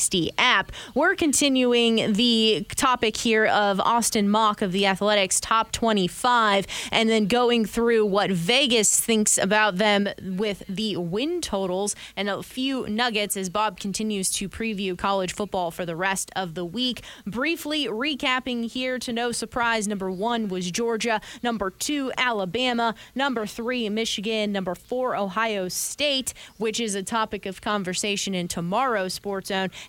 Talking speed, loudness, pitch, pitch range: 150 wpm, -23 LUFS, 215 Hz, 195-235 Hz